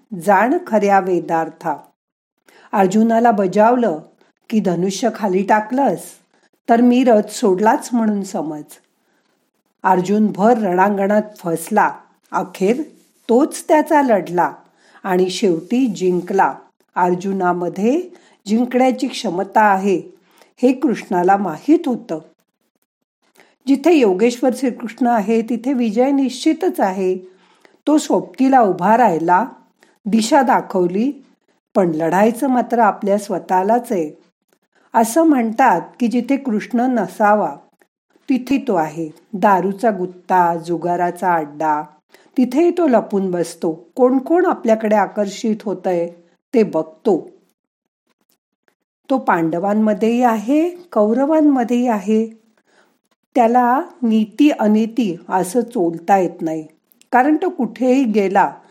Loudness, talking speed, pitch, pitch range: -17 LUFS, 95 wpm, 215 Hz, 185-250 Hz